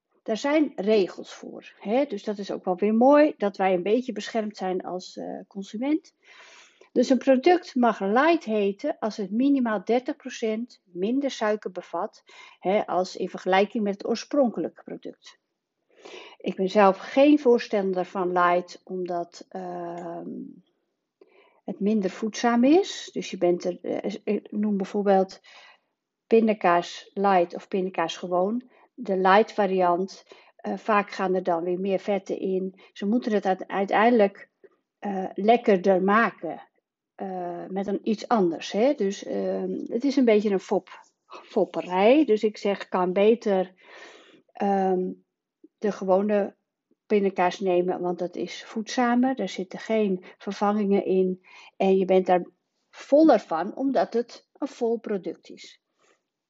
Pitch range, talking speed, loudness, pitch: 185-245 Hz, 140 wpm, -24 LUFS, 205 Hz